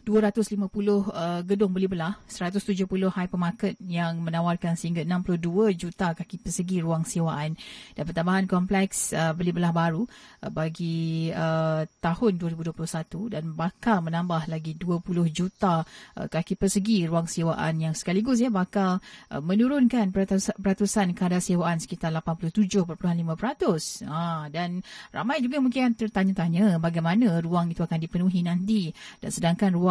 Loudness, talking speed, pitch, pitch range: -26 LUFS, 130 wpm, 180 Hz, 165-205 Hz